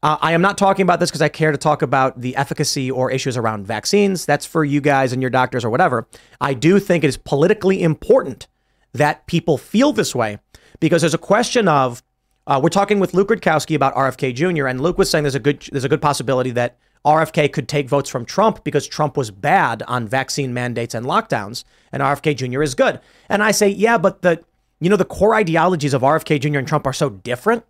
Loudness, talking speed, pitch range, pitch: -18 LUFS, 225 wpm, 130-175 Hz, 150 Hz